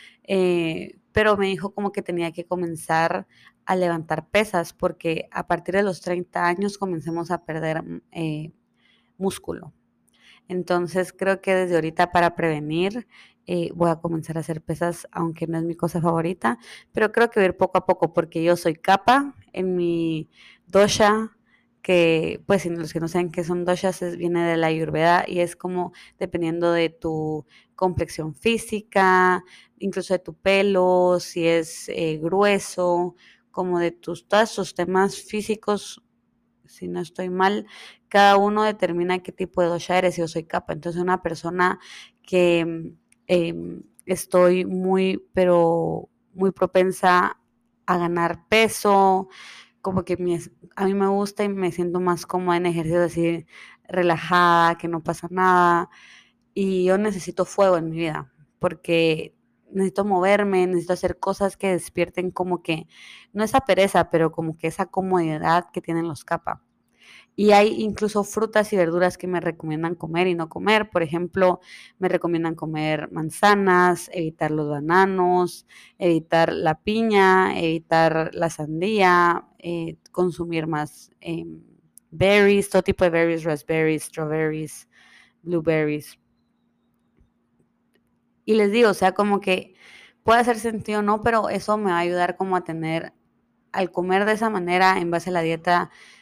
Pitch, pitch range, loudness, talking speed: 180 Hz, 165-190 Hz, -22 LUFS, 150 wpm